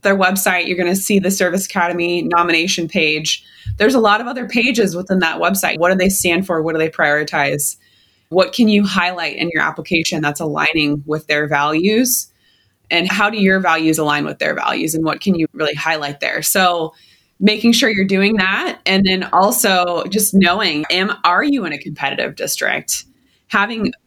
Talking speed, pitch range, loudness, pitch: 185 wpm, 160-195 Hz, -15 LUFS, 175 Hz